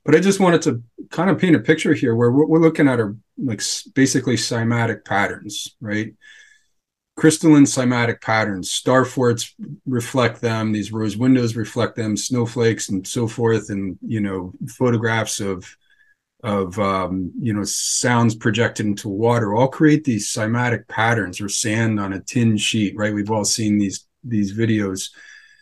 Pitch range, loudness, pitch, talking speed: 105-130 Hz, -19 LUFS, 115 Hz, 160 wpm